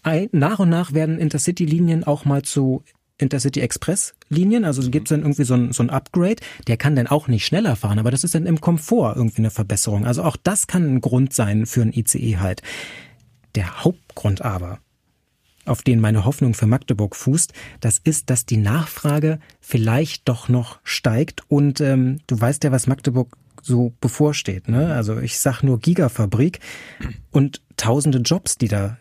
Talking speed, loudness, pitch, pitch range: 180 wpm, -19 LUFS, 130 Hz, 115-150 Hz